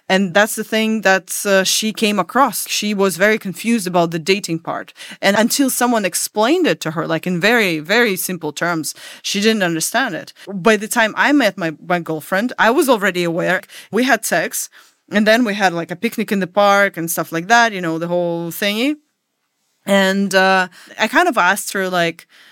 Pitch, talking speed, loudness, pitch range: 195 Hz, 205 wpm, -16 LUFS, 175-220 Hz